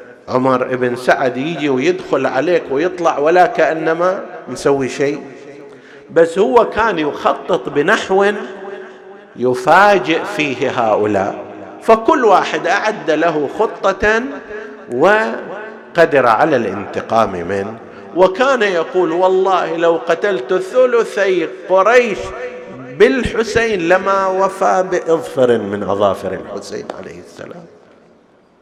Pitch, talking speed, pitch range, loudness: 185 Hz, 90 wpm, 135-210 Hz, -14 LUFS